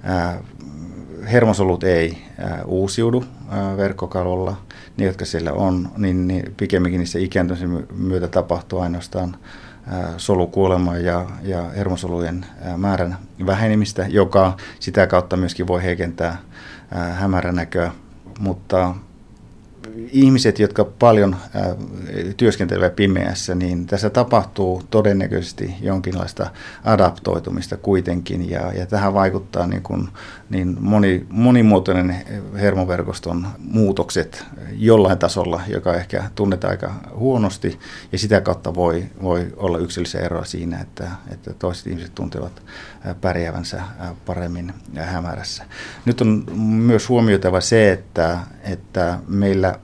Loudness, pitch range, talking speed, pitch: -20 LUFS, 90-100 Hz, 105 wpm, 95 Hz